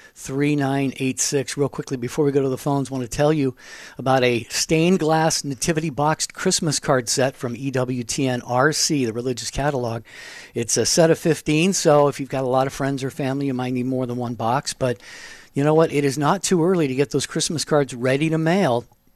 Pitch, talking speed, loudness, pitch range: 140 Hz, 210 wpm, -21 LUFS, 130-155 Hz